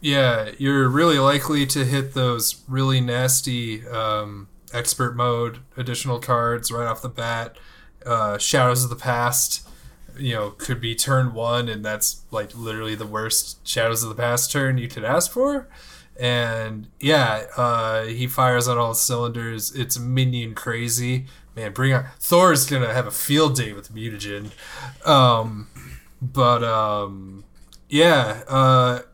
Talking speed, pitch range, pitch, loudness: 145 wpm, 110-130 Hz, 120 Hz, -21 LUFS